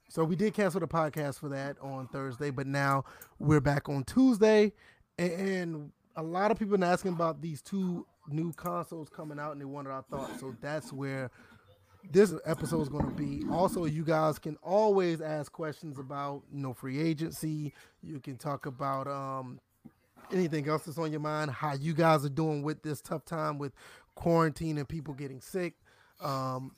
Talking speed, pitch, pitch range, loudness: 190 wpm, 155 Hz, 140-165 Hz, -32 LUFS